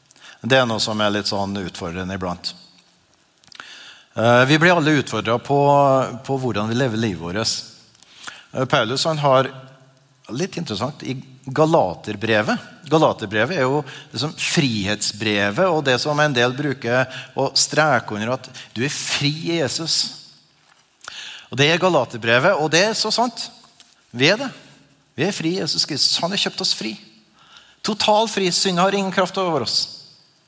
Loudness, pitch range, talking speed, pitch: -19 LUFS, 115-160 Hz, 155 wpm, 135 Hz